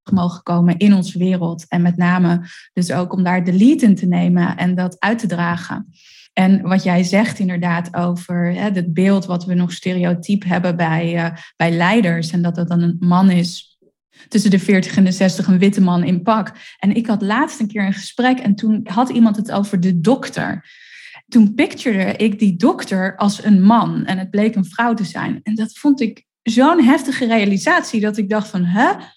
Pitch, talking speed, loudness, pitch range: 195 Hz, 205 wpm, -16 LUFS, 180-220 Hz